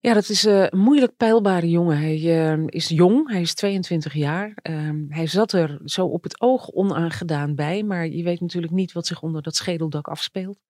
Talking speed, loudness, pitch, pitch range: 190 wpm, -21 LUFS, 175 Hz, 160-195 Hz